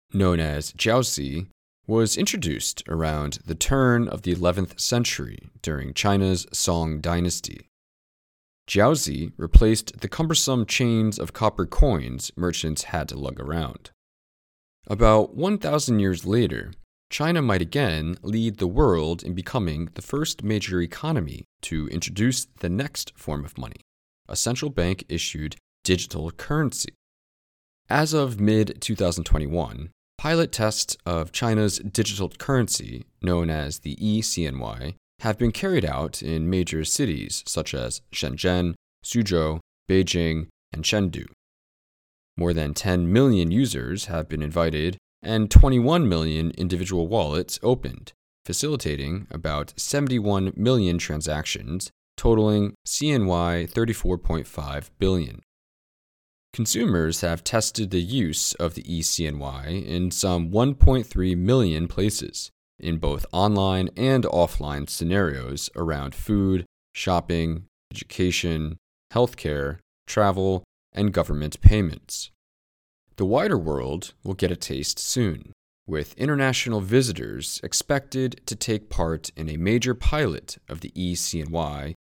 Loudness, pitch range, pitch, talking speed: -24 LUFS, 80-110 Hz, 90 Hz, 115 wpm